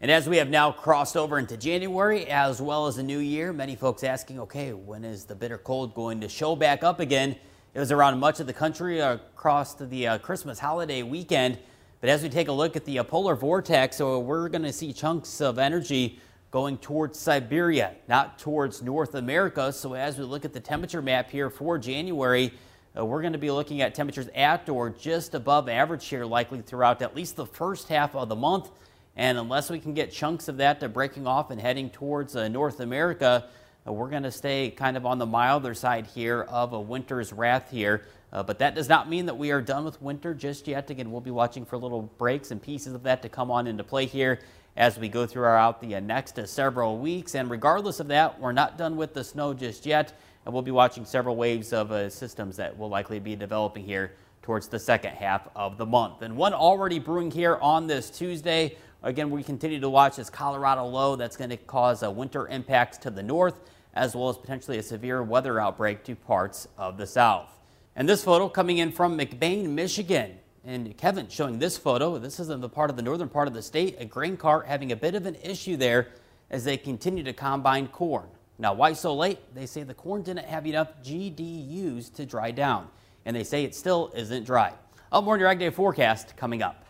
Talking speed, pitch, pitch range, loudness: 220 wpm, 135 Hz, 120-155 Hz, -27 LUFS